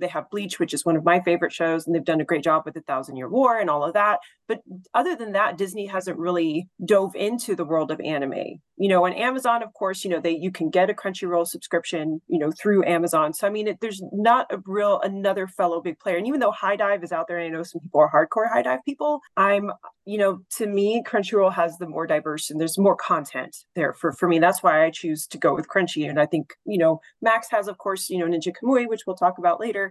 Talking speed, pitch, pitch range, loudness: 265 wpm, 180 Hz, 165-205 Hz, -23 LUFS